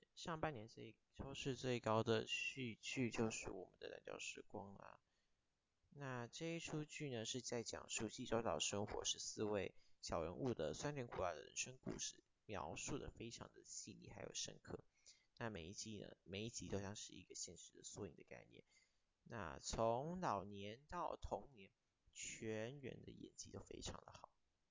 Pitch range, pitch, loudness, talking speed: 110-135 Hz, 115 Hz, -48 LUFS, 250 characters per minute